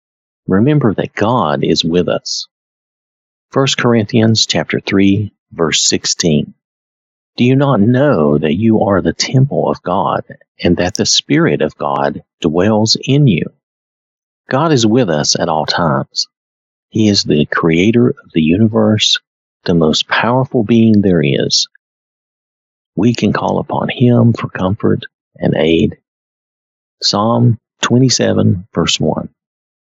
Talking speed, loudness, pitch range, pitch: 130 wpm, -13 LUFS, 85-120 Hz, 110 Hz